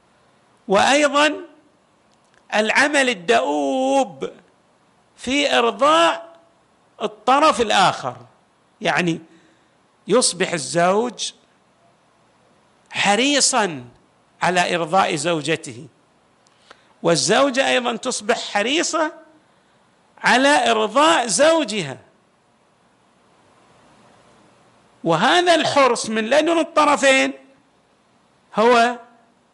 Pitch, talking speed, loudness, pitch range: 245 Hz, 55 wpm, -18 LUFS, 205-285 Hz